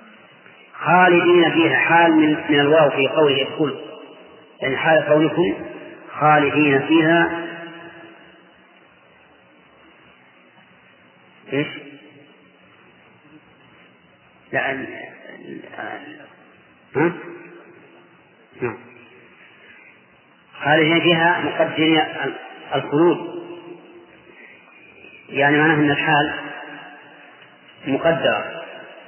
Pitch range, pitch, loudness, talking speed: 145-170 Hz, 155 Hz, -17 LUFS, 55 wpm